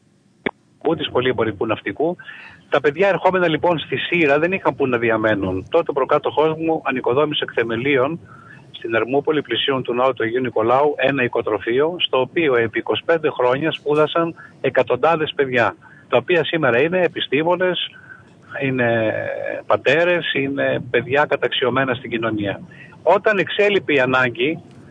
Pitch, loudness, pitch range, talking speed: 140 Hz, -19 LUFS, 120-165 Hz, 135 wpm